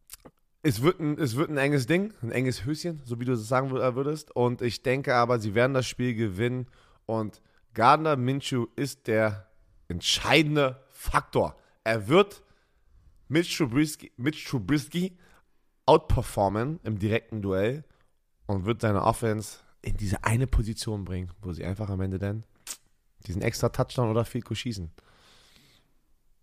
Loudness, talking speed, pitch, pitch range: -27 LUFS, 145 wpm, 120 Hz, 110-135 Hz